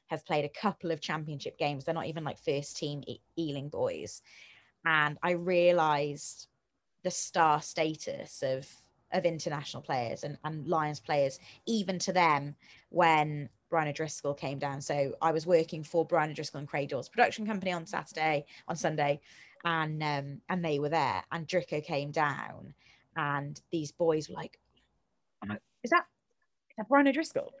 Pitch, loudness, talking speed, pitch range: 155 Hz, -32 LUFS, 165 wpm, 145-170 Hz